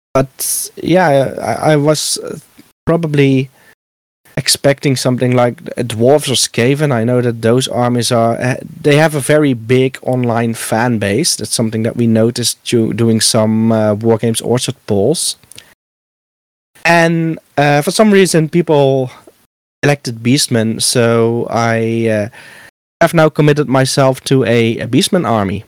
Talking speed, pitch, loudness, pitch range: 135 wpm, 125 Hz, -13 LUFS, 115-145 Hz